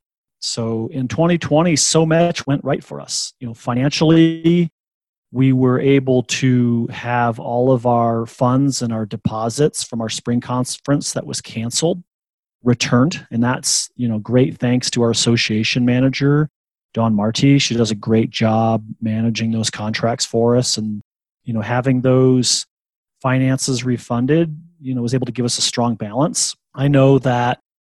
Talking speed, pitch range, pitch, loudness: 160 wpm, 115-135 Hz, 125 Hz, -17 LUFS